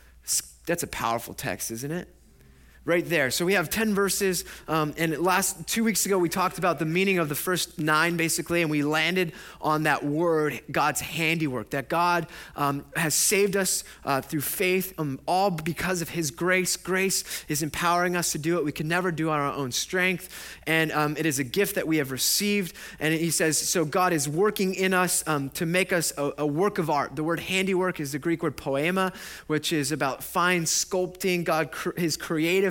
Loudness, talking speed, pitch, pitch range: -25 LUFS, 205 wpm, 165 Hz, 150-185 Hz